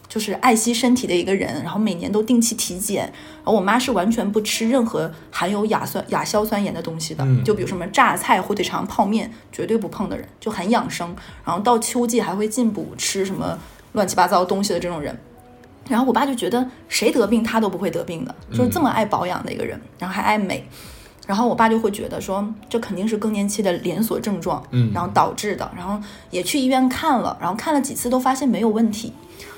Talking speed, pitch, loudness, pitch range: 335 characters per minute, 215 Hz, -21 LUFS, 185-235 Hz